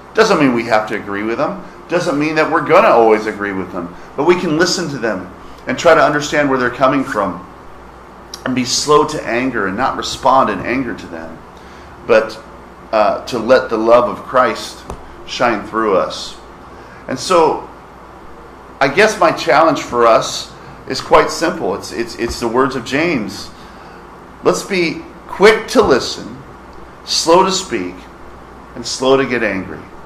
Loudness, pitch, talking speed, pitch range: -14 LUFS, 115 Hz, 170 wpm, 90-135 Hz